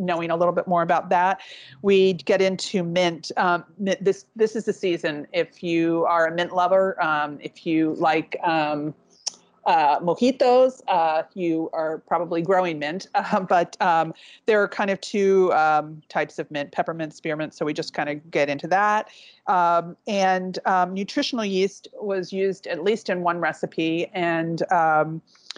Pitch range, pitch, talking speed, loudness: 160-195 Hz, 175 Hz, 170 wpm, -23 LUFS